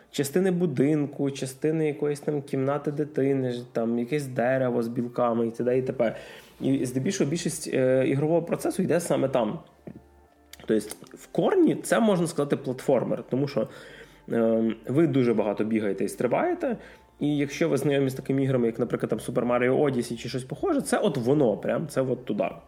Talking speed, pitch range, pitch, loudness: 170 wpm, 120-150 Hz, 130 Hz, -26 LUFS